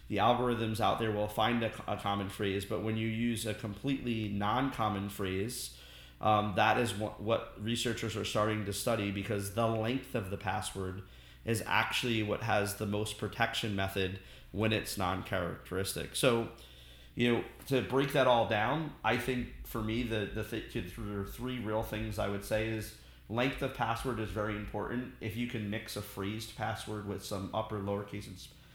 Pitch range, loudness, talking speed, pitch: 100-115 Hz, -34 LUFS, 180 wpm, 110 Hz